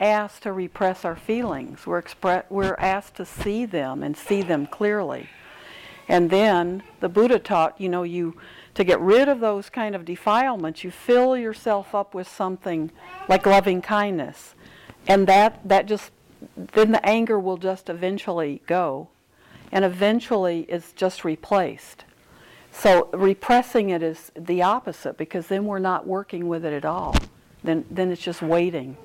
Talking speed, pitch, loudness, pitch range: 160 wpm, 190 Hz, -22 LUFS, 175-210 Hz